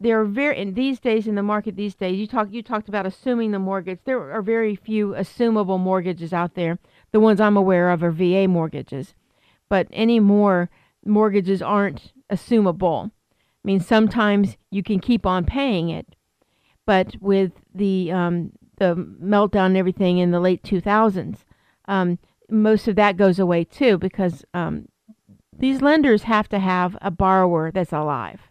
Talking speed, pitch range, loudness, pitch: 165 wpm, 180-215 Hz, -20 LUFS, 195 Hz